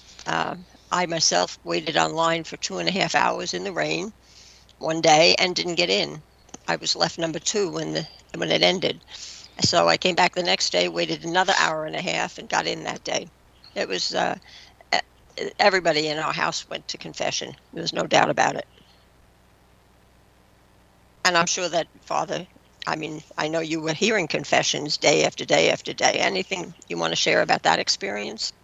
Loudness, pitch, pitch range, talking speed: -23 LUFS, 165 Hz, 155-180 Hz, 190 wpm